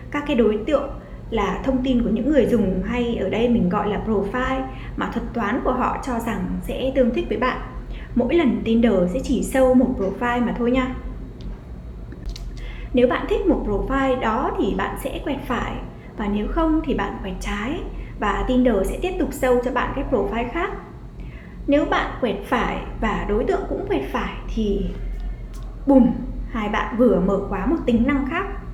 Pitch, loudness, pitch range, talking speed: 245 Hz, -22 LUFS, 210-265 Hz, 190 wpm